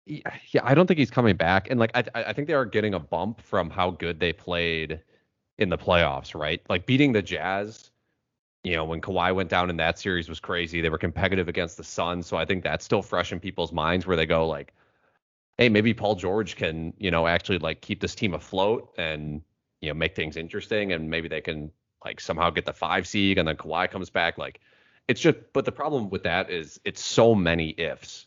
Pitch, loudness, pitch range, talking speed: 90 Hz, -26 LUFS, 80-105 Hz, 225 wpm